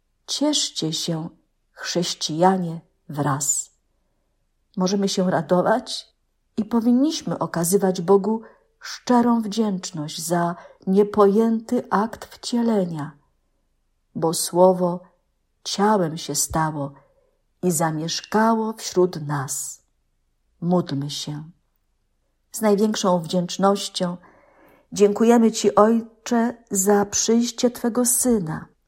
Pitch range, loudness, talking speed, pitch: 165-225 Hz, -21 LUFS, 80 wpm, 190 Hz